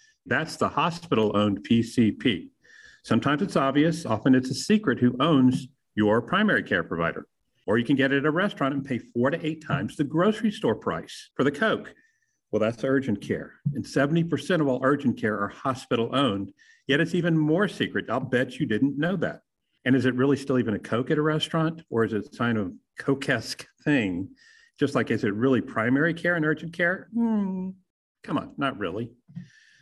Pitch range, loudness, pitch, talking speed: 125-165 Hz, -25 LUFS, 140 Hz, 195 wpm